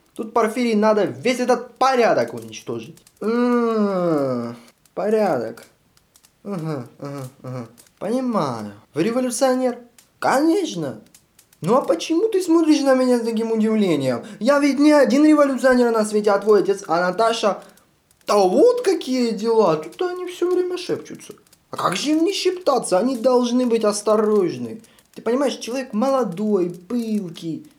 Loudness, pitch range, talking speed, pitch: -19 LUFS, 200-265 Hz, 135 wpm, 230 Hz